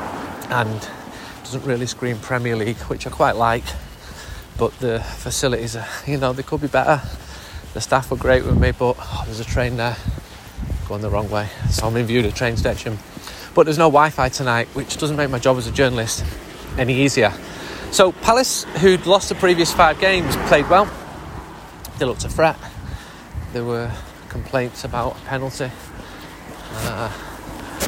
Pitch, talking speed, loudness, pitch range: 120 Hz, 170 wpm, -19 LUFS, 105-135 Hz